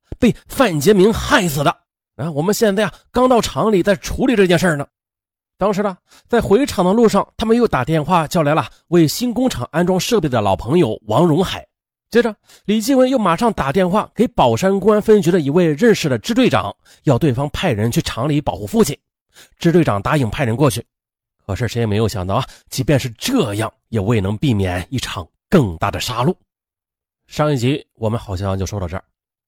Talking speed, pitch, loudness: 295 characters per minute, 155 Hz, -17 LUFS